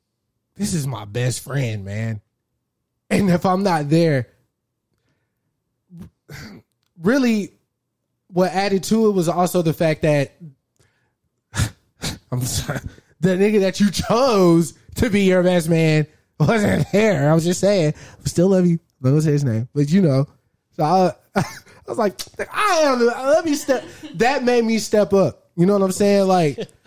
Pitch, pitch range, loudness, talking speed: 170 Hz, 135-195 Hz, -19 LUFS, 155 wpm